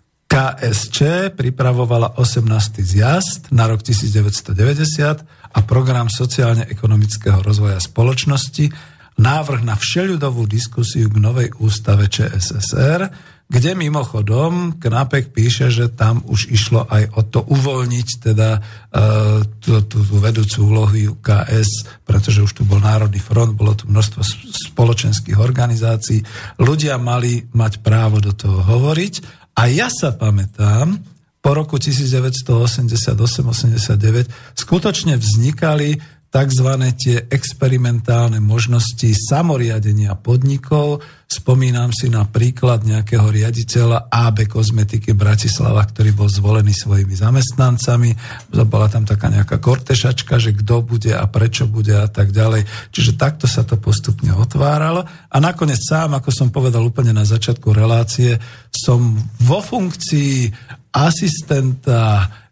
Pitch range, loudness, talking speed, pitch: 110-130 Hz, -15 LUFS, 115 wpm, 120 Hz